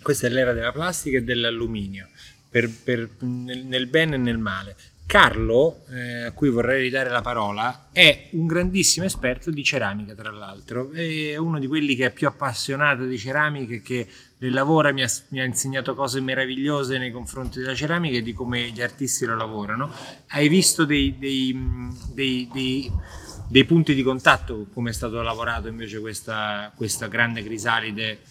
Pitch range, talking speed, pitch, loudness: 115-140 Hz, 170 wpm, 125 Hz, -22 LUFS